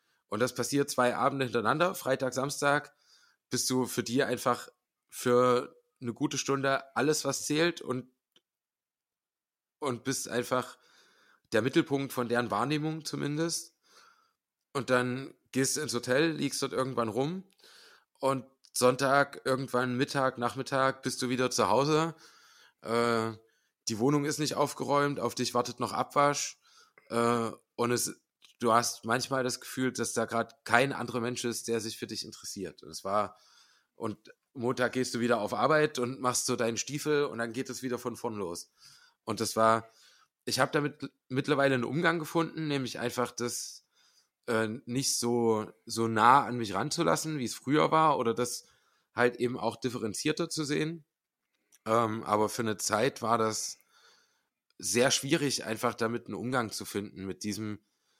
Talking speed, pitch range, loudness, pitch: 160 wpm, 115-140 Hz, -30 LUFS, 125 Hz